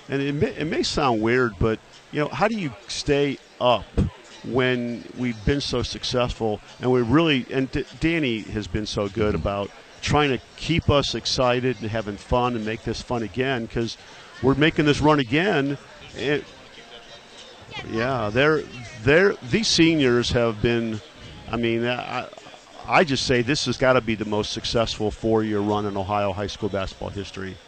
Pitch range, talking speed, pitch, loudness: 110-135 Hz, 175 wpm, 120 Hz, -23 LUFS